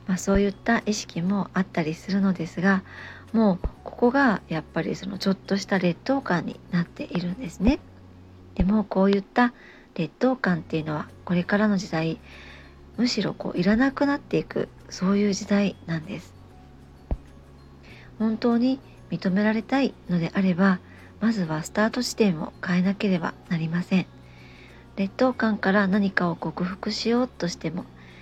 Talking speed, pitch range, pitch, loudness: 320 characters per minute, 165-215 Hz, 190 Hz, -25 LUFS